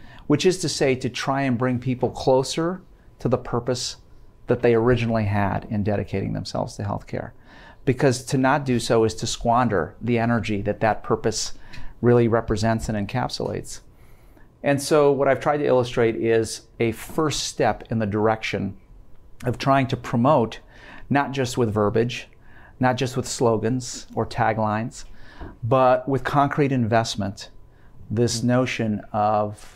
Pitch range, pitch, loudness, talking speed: 110-130 Hz, 120 Hz, -23 LUFS, 150 wpm